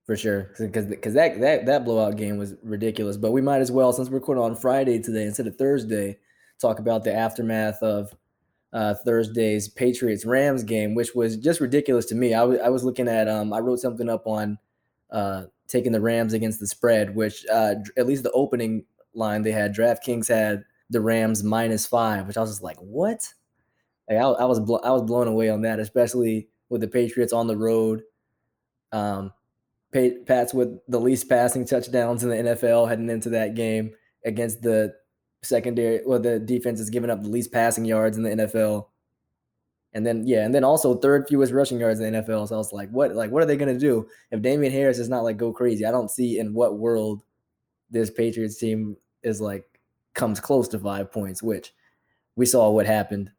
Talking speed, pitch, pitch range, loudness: 205 wpm, 115 Hz, 110-125 Hz, -23 LUFS